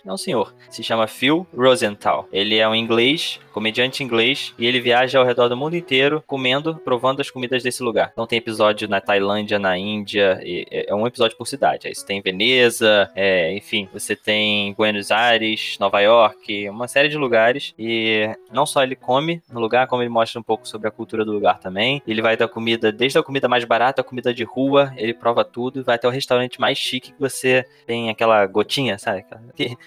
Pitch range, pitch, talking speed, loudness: 110-130 Hz, 120 Hz, 205 wpm, -19 LUFS